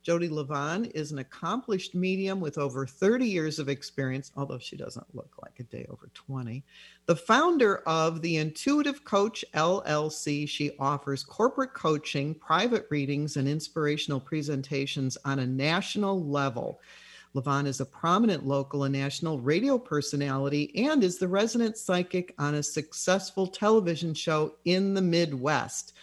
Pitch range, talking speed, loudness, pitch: 140-185 Hz, 145 wpm, -28 LUFS, 155 Hz